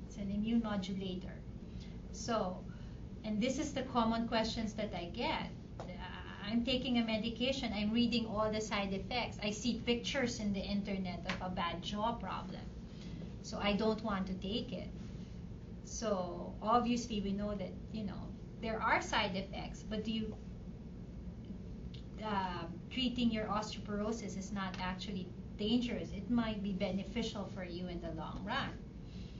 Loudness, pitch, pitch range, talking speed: -38 LUFS, 210 Hz, 195-230 Hz, 150 wpm